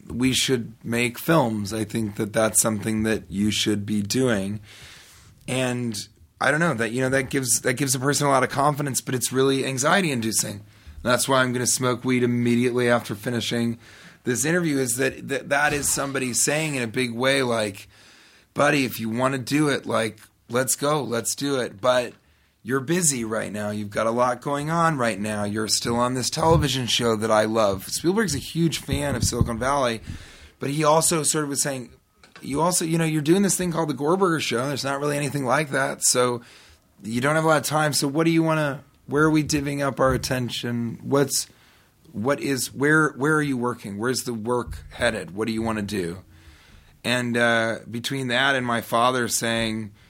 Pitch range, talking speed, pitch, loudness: 115-140 Hz, 210 wpm, 125 Hz, -23 LUFS